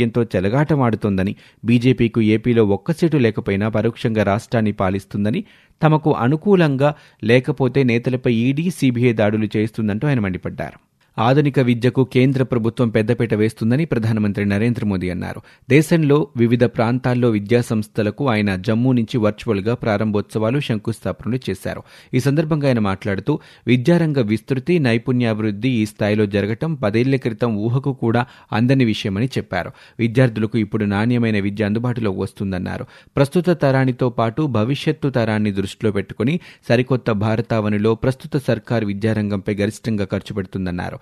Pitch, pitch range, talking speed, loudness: 115 Hz, 105-130 Hz, 115 wpm, -19 LUFS